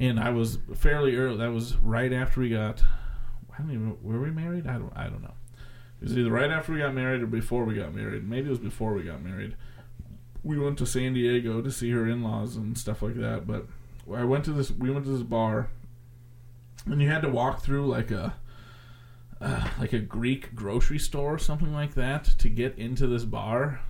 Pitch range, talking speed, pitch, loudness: 115-130 Hz, 220 wpm, 120 Hz, -29 LUFS